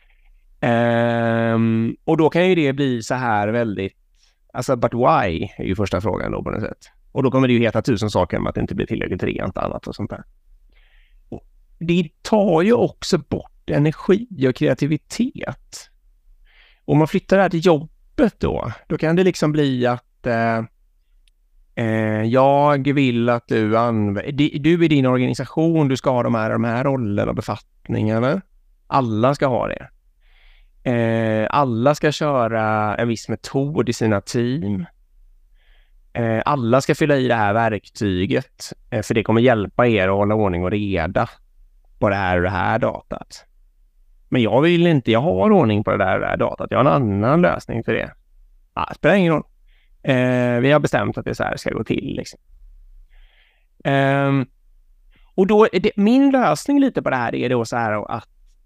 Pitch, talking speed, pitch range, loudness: 120 Hz, 180 wpm, 105-145 Hz, -19 LUFS